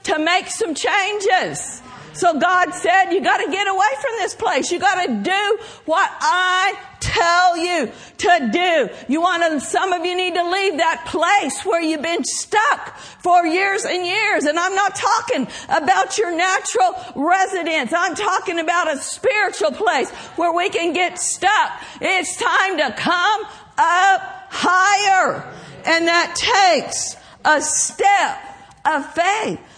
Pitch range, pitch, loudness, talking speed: 340-395 Hz, 365 Hz, -18 LUFS, 145 wpm